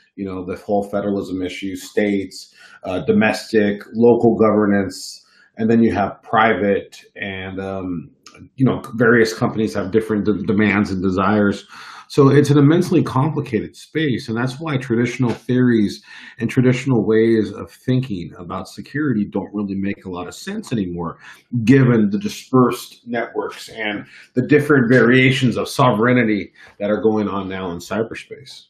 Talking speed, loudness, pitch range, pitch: 150 wpm, -18 LUFS, 100-125 Hz, 110 Hz